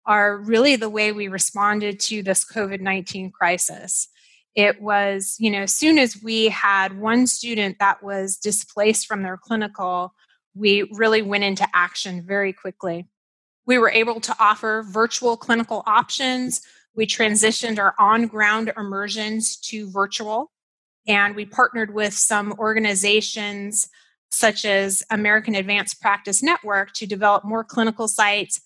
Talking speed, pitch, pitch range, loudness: 140 wpm, 210 Hz, 200-220 Hz, -20 LUFS